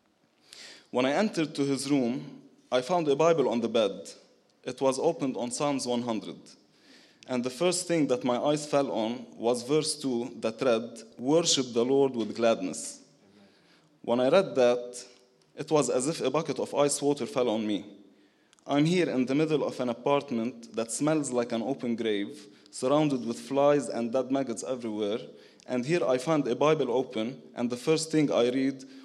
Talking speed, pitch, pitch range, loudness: 180 wpm, 130 Hz, 120-145 Hz, -28 LUFS